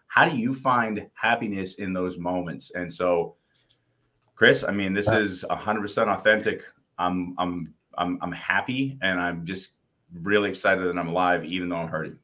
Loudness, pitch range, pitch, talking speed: -25 LUFS, 90-105 Hz, 90 Hz, 165 wpm